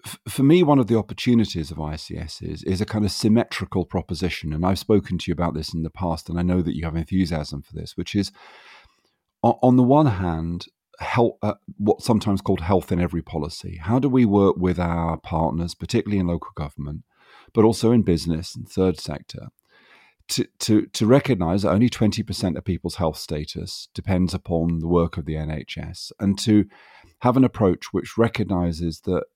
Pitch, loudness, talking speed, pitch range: 95 Hz, -22 LUFS, 190 wpm, 85-110 Hz